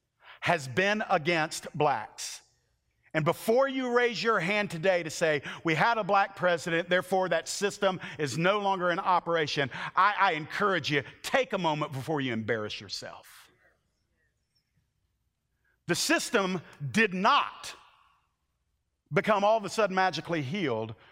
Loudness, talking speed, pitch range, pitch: -28 LUFS, 135 wpm, 155-205 Hz, 180 Hz